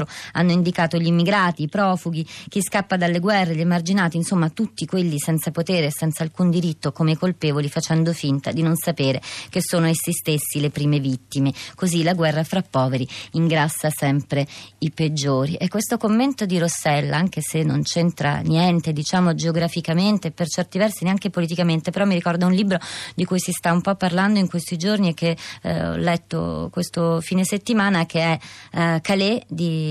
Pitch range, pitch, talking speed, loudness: 155-180 Hz, 170 Hz, 175 wpm, -21 LUFS